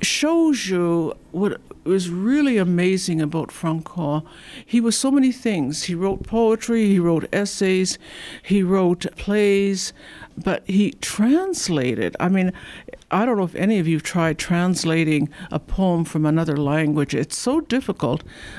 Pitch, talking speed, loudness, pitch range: 185 Hz, 145 wpm, -21 LUFS, 160-210 Hz